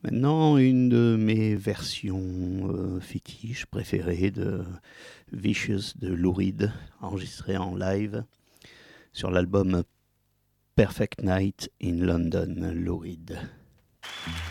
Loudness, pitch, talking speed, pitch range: -27 LUFS, 95 Hz, 95 wpm, 90-105 Hz